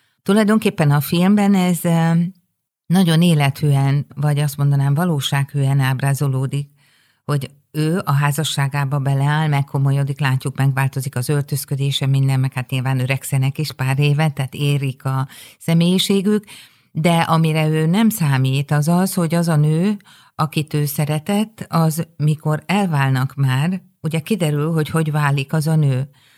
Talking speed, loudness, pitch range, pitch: 135 wpm, -18 LUFS, 140-165 Hz, 145 Hz